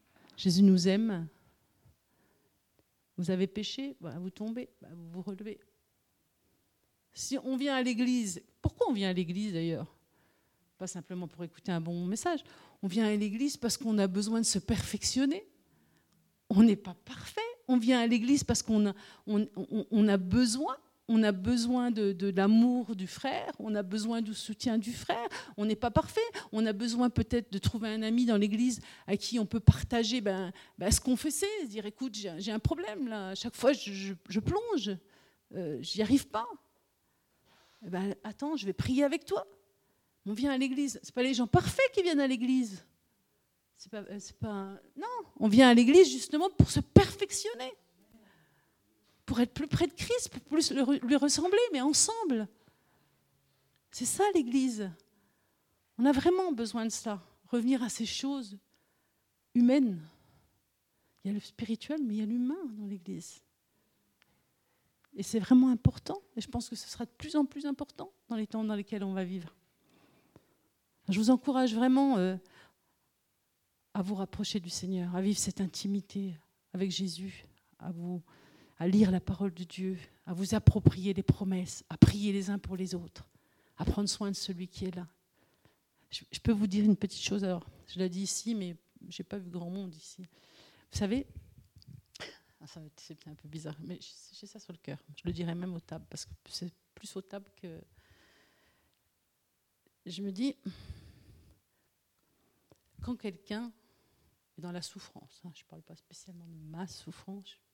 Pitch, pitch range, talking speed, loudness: 210 Hz, 185-250 Hz, 175 wpm, -31 LUFS